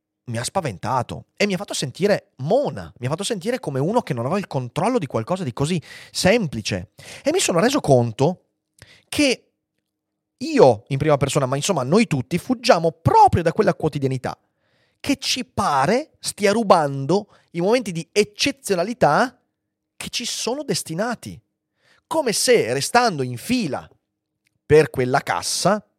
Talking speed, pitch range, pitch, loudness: 150 wpm, 140-220 Hz, 175 Hz, -20 LUFS